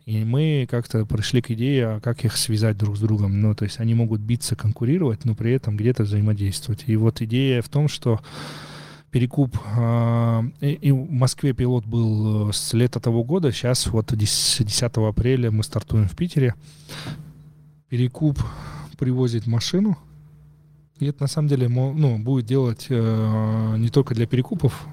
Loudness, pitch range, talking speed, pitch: -22 LUFS, 110-140 Hz, 155 wpm, 120 Hz